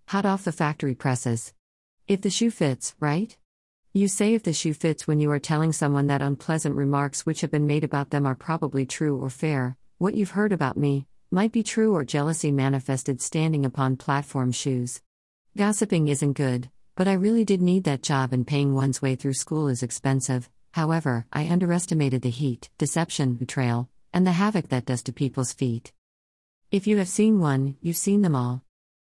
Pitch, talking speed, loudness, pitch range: 145 Hz, 190 wpm, -25 LUFS, 130-170 Hz